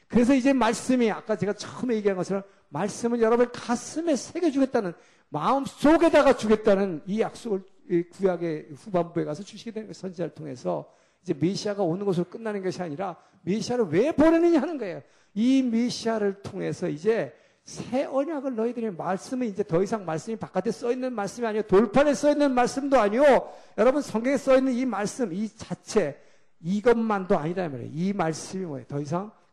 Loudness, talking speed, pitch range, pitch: -25 LUFS, 390 characters per minute, 185-250 Hz, 215 Hz